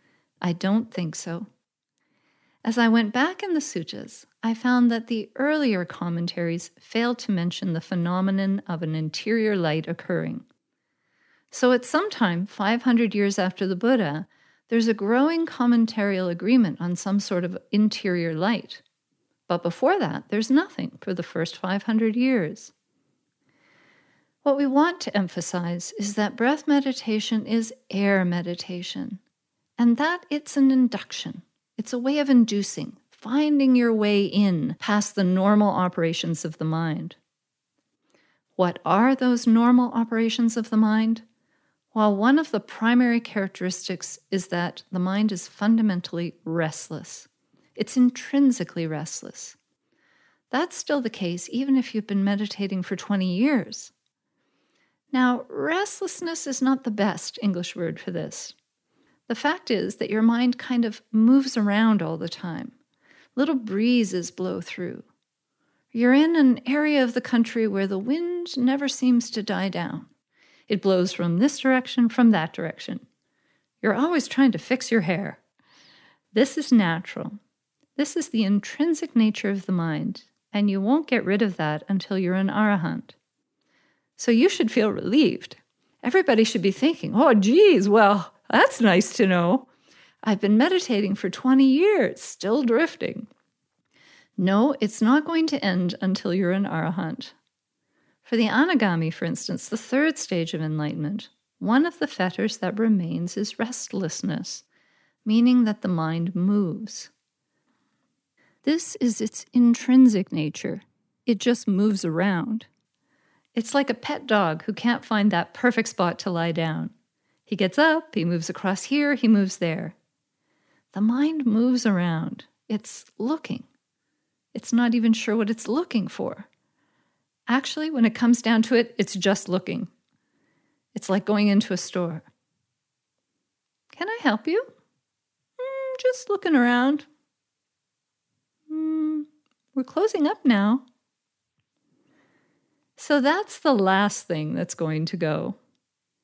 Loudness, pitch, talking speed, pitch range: -23 LUFS, 220 Hz, 140 wpm, 190-255 Hz